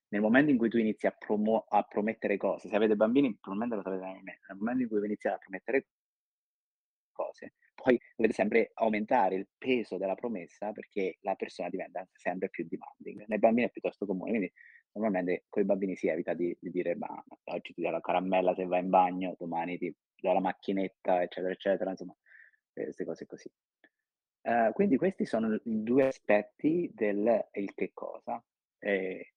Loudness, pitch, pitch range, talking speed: -31 LUFS, 100 Hz, 90-110 Hz, 185 wpm